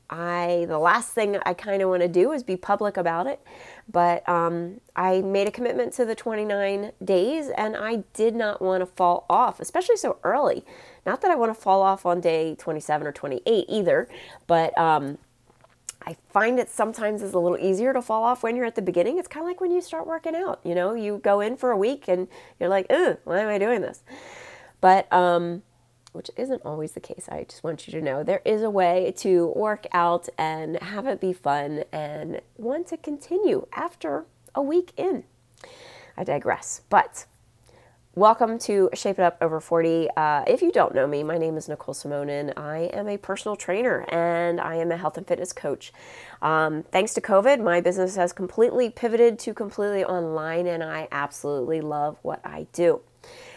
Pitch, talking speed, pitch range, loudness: 190 Hz, 200 wpm, 170-230 Hz, -24 LUFS